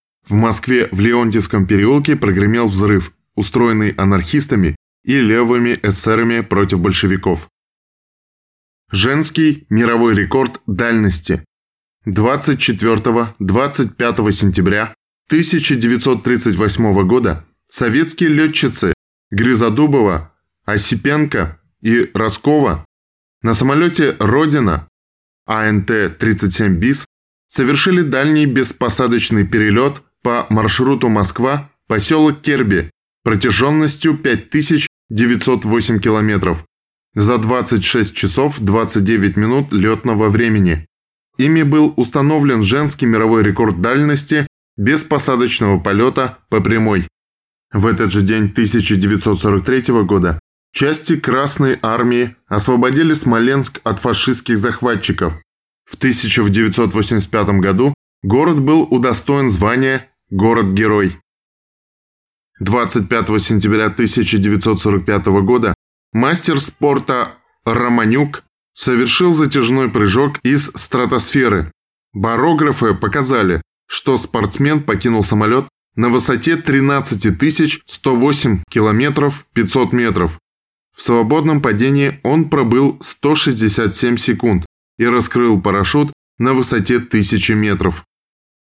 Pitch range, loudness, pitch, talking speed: 105-135 Hz, -14 LUFS, 115 Hz, 85 wpm